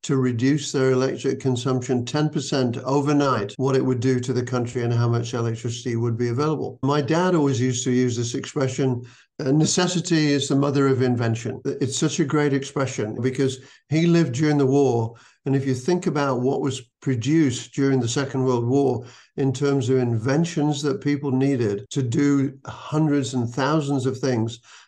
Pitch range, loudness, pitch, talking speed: 125-145 Hz, -22 LUFS, 135 Hz, 175 wpm